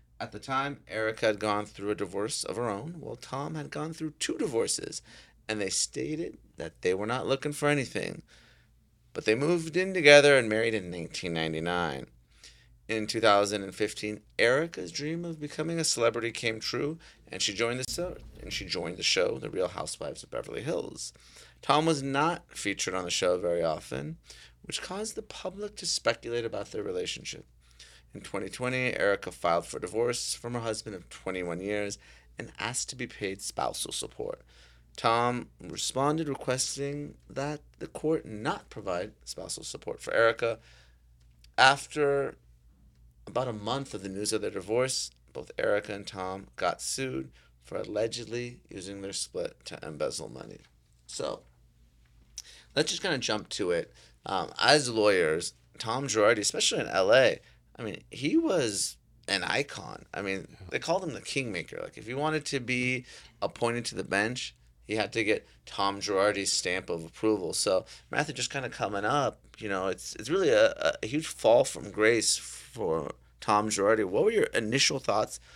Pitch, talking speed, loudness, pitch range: 110 Hz, 170 wpm, -29 LUFS, 90-145 Hz